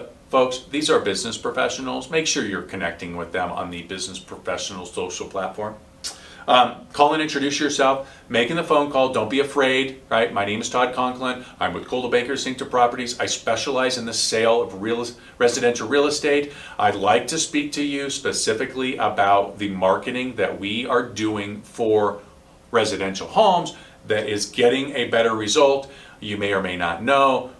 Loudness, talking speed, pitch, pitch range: -21 LUFS, 175 wpm, 125 Hz, 105-140 Hz